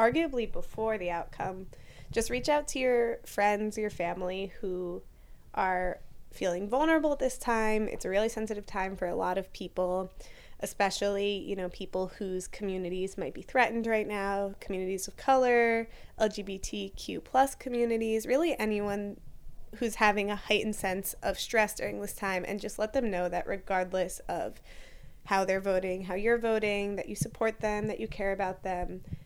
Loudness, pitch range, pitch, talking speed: -31 LUFS, 185-225 Hz, 200 Hz, 165 wpm